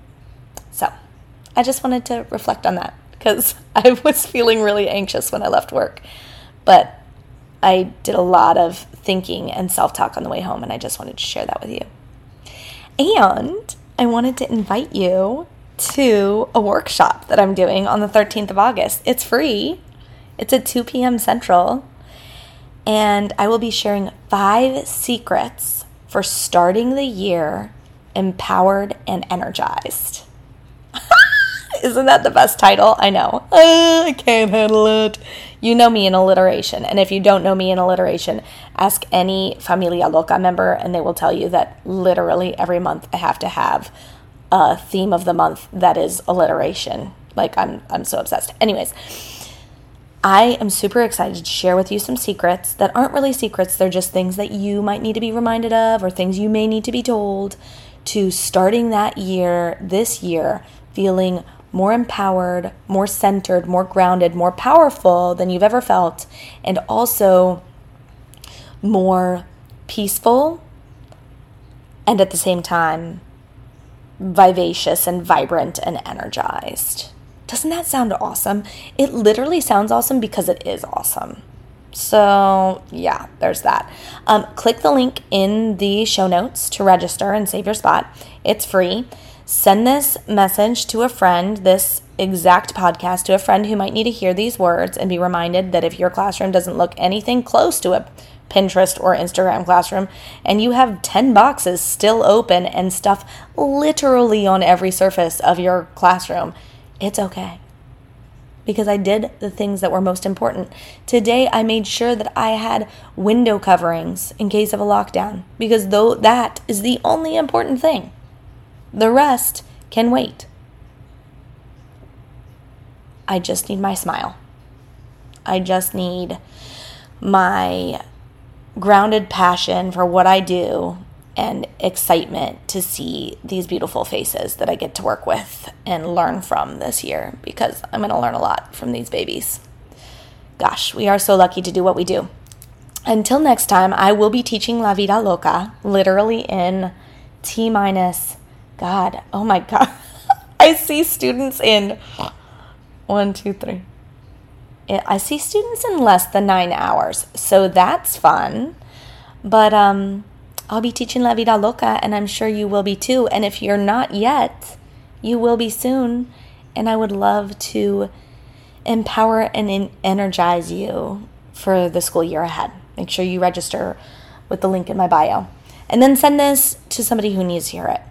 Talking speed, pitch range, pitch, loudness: 160 wpm, 175-220 Hz, 190 Hz, -16 LUFS